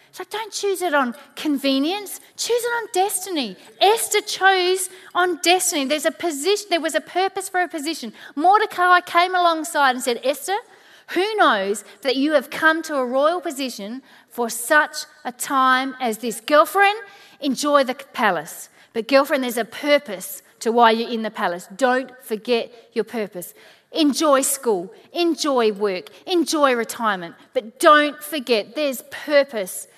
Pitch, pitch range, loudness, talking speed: 295 Hz, 245-360 Hz, -20 LUFS, 150 wpm